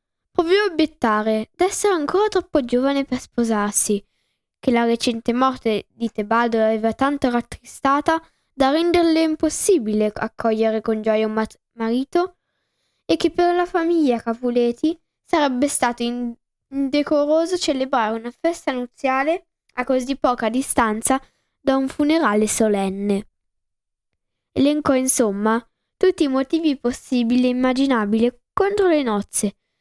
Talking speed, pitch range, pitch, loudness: 120 wpm, 230-315 Hz, 260 Hz, -20 LUFS